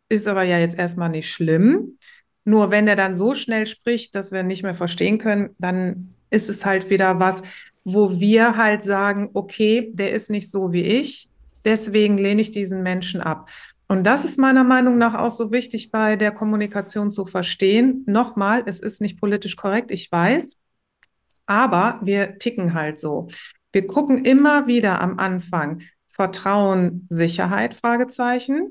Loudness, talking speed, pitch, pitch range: -20 LUFS, 165 wpm, 205 Hz, 190-230 Hz